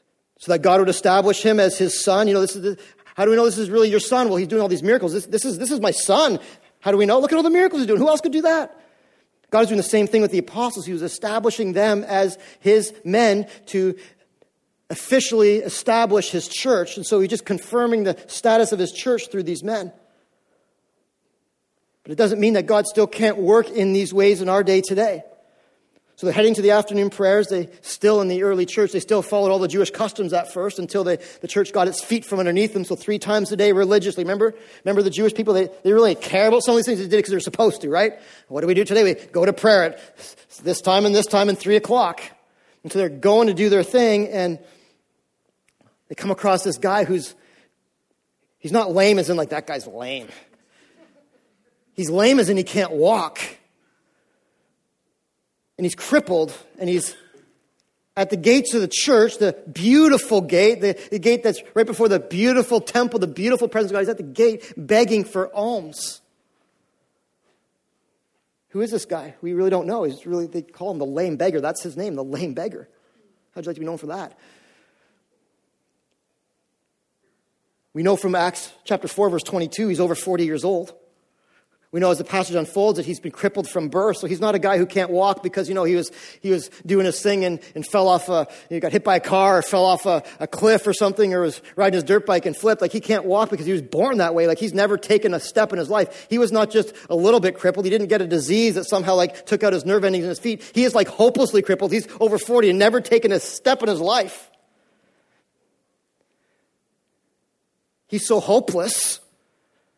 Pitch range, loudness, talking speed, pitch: 185-220 Hz, -19 LUFS, 220 wpm, 200 Hz